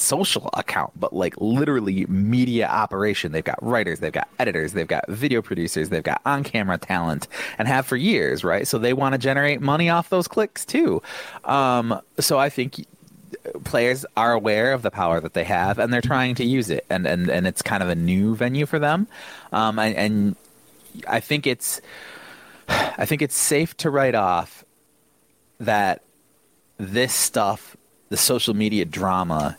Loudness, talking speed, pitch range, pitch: -22 LUFS, 175 wpm, 100-145 Hz, 125 Hz